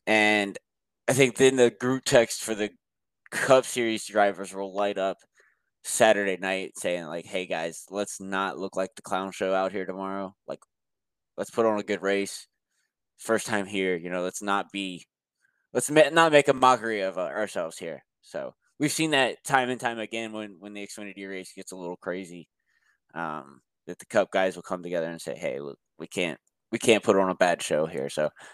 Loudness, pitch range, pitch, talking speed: -26 LUFS, 95-115 Hz, 100 Hz, 200 wpm